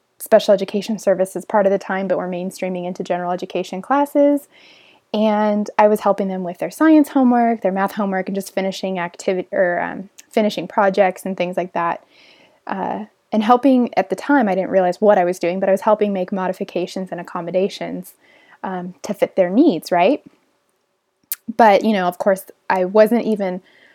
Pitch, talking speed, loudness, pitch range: 195 Hz, 185 wpm, -18 LUFS, 185-220 Hz